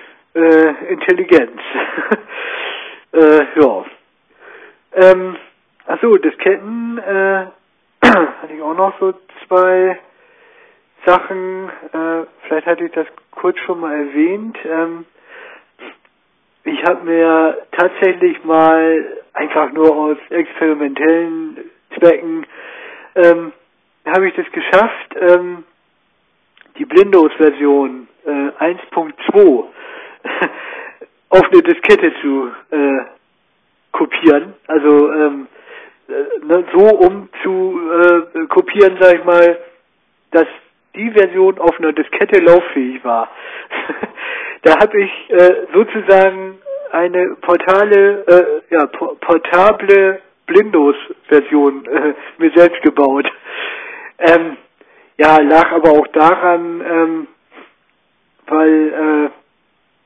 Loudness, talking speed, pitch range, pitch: -12 LUFS, 95 wpm, 160-235 Hz, 180 Hz